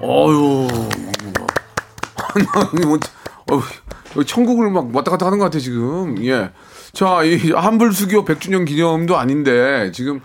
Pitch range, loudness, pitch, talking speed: 140-190 Hz, -16 LUFS, 165 Hz, 225 characters per minute